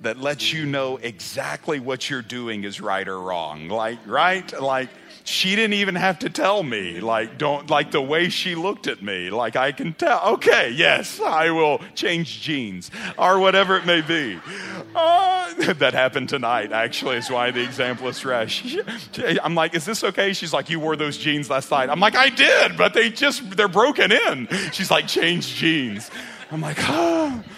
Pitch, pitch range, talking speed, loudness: 160 Hz, 125-195 Hz, 185 wpm, -20 LUFS